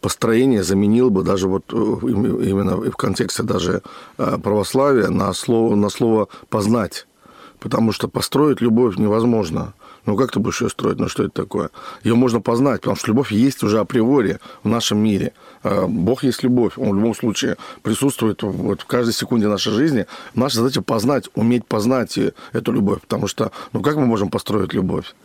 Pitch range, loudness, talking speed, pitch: 105-120 Hz, -19 LUFS, 170 wpm, 115 Hz